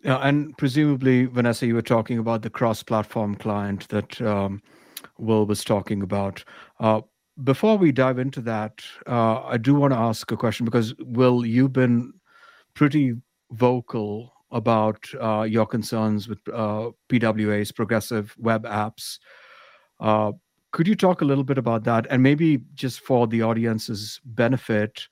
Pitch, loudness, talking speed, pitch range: 115 Hz, -23 LUFS, 155 wpm, 110-130 Hz